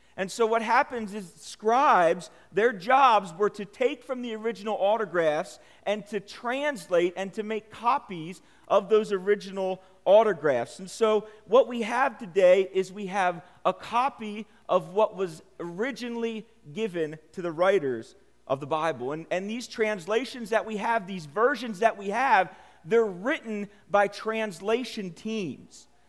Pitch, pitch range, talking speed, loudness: 210 Hz, 190-230 Hz, 150 wpm, -27 LUFS